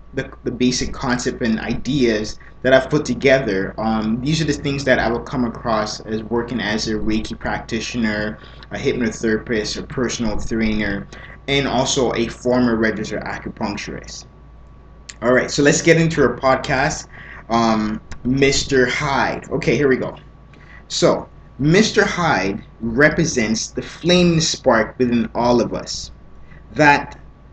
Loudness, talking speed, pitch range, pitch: -19 LUFS, 140 wpm, 110-140 Hz, 125 Hz